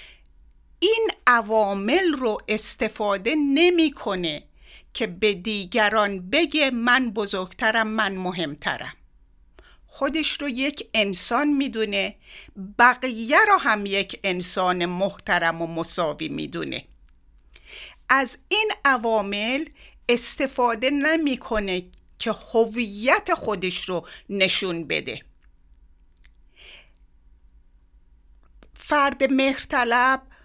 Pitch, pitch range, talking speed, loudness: 215 Hz, 175-265 Hz, 80 wpm, -21 LUFS